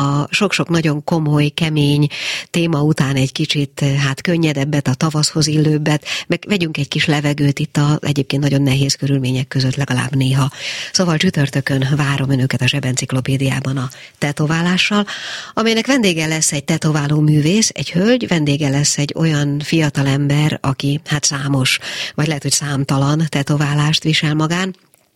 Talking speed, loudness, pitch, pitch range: 145 wpm, -16 LUFS, 145 Hz, 140-160 Hz